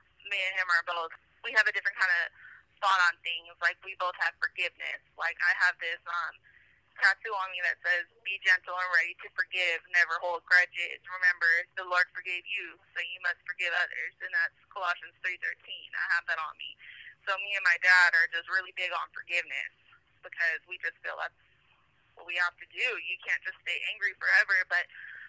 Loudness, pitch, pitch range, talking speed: -29 LUFS, 180 Hz, 175-190 Hz, 205 wpm